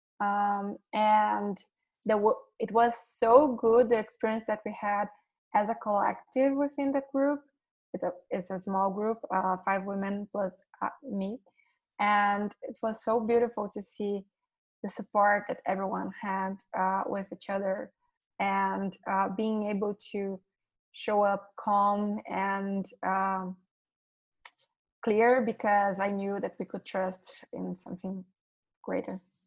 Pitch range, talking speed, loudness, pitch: 195-230 Hz, 135 wpm, -30 LUFS, 205 Hz